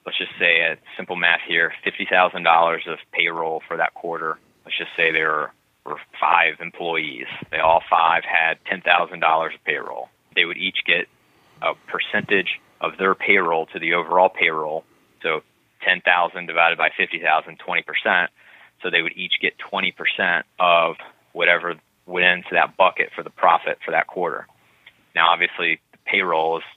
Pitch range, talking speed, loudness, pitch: 80-85 Hz, 155 wpm, -20 LUFS, 80 Hz